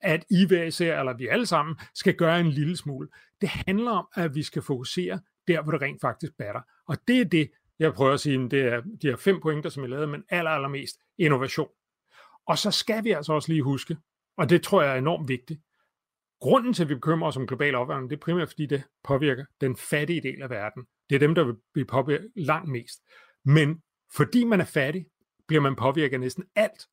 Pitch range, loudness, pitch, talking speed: 135-175 Hz, -26 LUFS, 155 Hz, 230 wpm